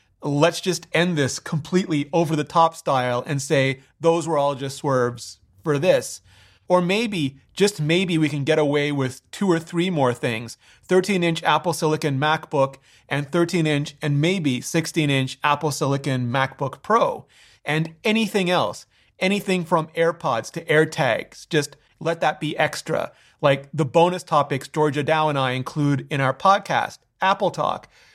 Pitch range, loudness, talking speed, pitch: 135-170 Hz, -22 LUFS, 160 wpm, 155 Hz